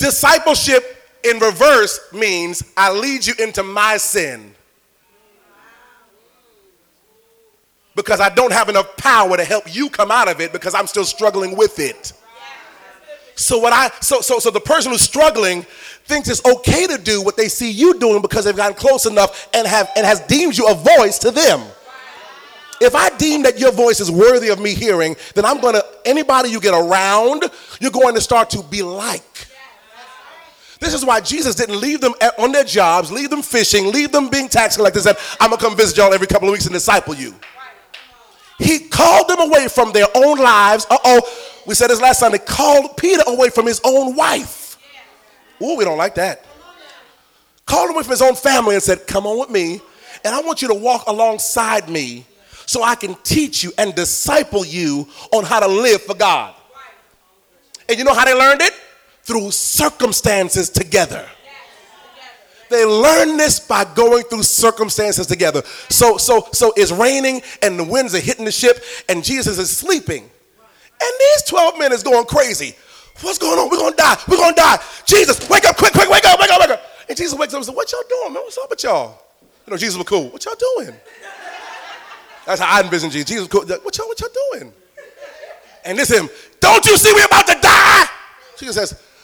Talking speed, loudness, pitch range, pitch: 200 wpm, -13 LUFS, 205-295 Hz, 235 Hz